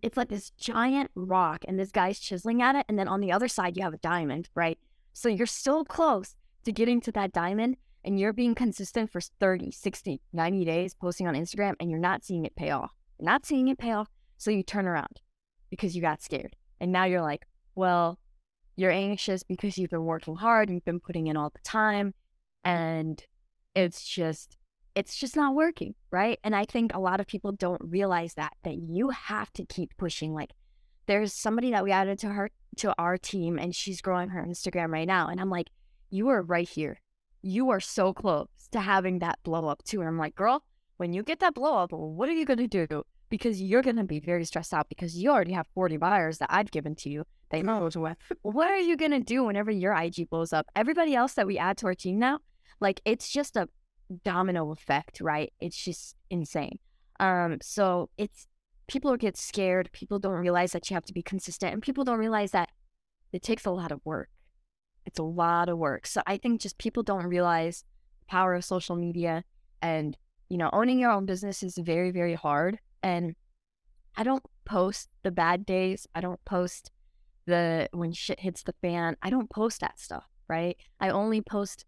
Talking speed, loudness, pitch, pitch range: 210 wpm, -29 LUFS, 185 Hz, 170-215 Hz